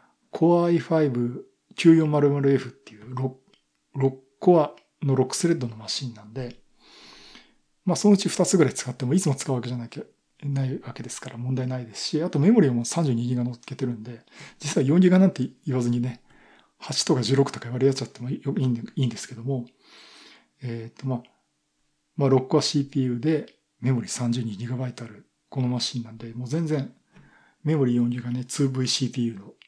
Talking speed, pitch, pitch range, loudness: 315 characters per minute, 130 Hz, 120-150 Hz, -24 LUFS